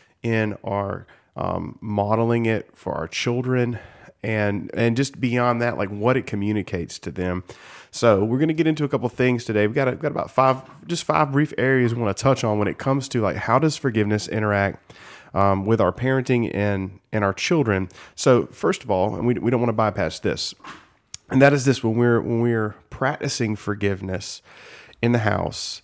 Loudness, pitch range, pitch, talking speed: -22 LUFS, 105-130 Hz, 115 Hz, 200 wpm